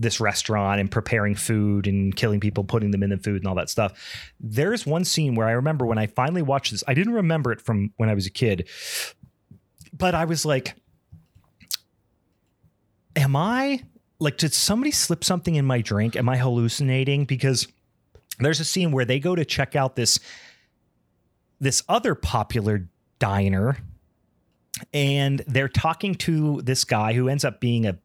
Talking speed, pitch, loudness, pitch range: 175 wpm, 125 Hz, -23 LUFS, 105-150 Hz